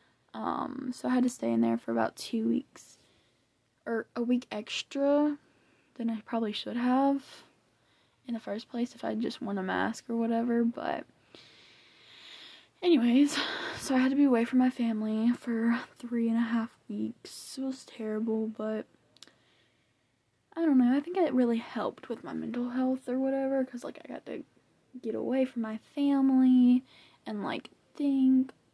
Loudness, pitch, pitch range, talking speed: -30 LUFS, 245 Hz, 230-270 Hz, 170 wpm